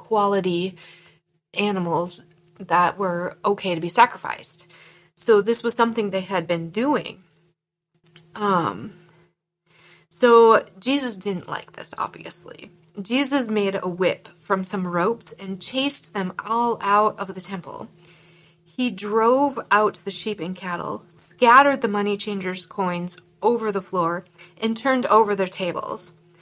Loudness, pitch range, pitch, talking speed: -22 LUFS, 175-220 Hz, 190 Hz, 130 wpm